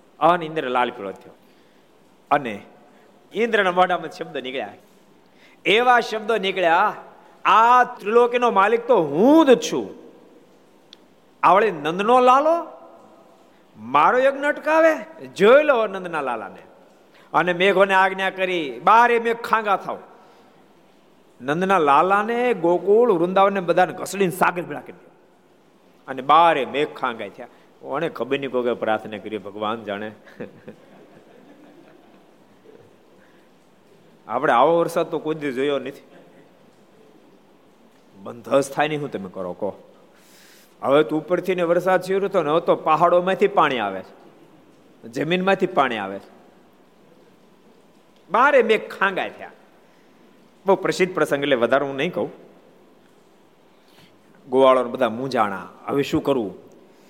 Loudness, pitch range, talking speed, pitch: -19 LUFS, 140-220 Hz, 115 wpm, 180 Hz